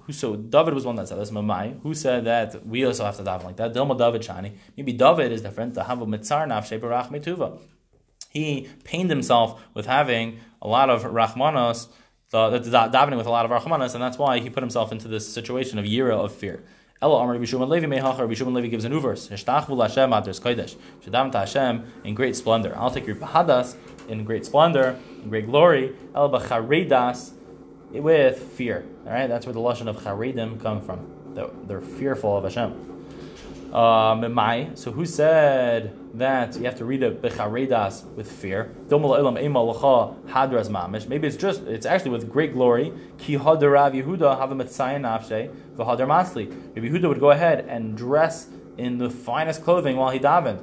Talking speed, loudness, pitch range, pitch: 140 wpm, -23 LUFS, 110-135 Hz, 120 Hz